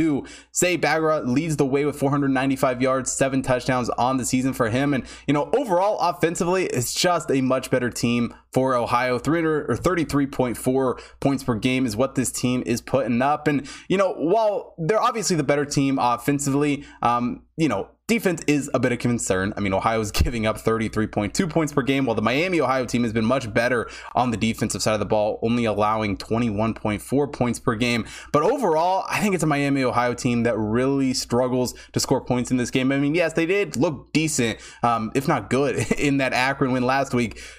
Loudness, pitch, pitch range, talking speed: -22 LUFS, 130 Hz, 120-145 Hz, 200 wpm